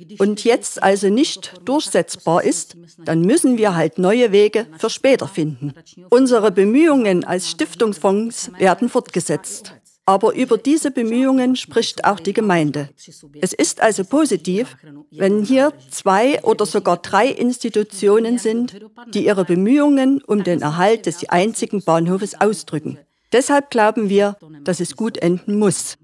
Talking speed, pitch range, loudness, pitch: 135 wpm, 175-235 Hz, -17 LUFS, 205 Hz